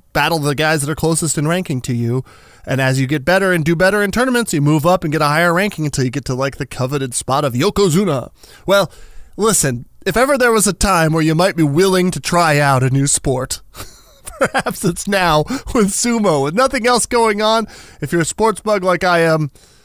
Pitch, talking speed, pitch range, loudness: 170 Hz, 225 wpm, 145-200 Hz, -15 LUFS